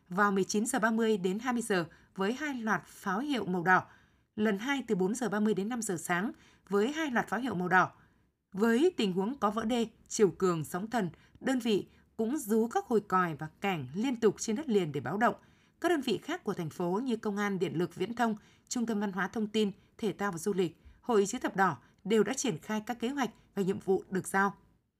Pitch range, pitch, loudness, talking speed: 190-230 Hz, 205 Hz, -32 LUFS, 225 wpm